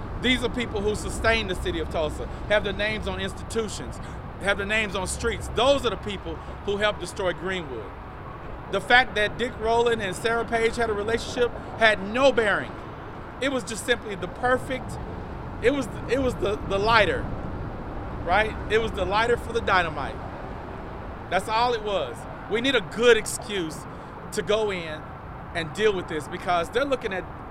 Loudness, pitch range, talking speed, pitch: -25 LUFS, 195-235 Hz, 180 wpm, 215 Hz